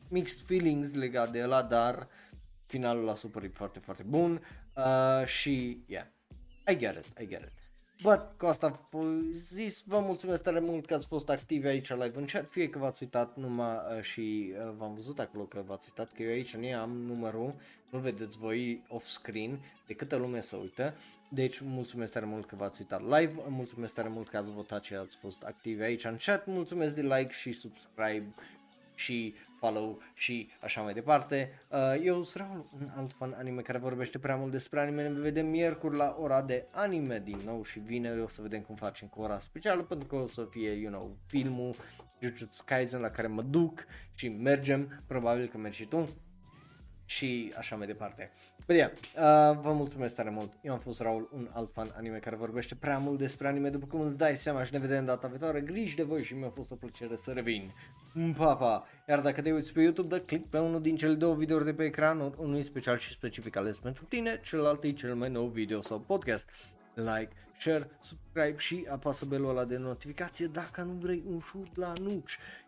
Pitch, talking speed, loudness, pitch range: 130 Hz, 205 wpm, -34 LUFS, 115-155 Hz